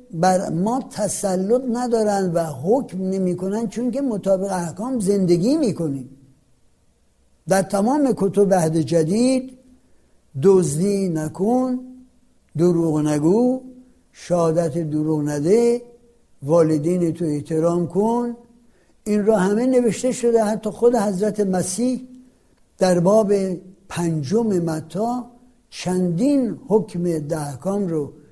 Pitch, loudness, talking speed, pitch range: 195 Hz, -20 LUFS, 100 wpm, 170-235 Hz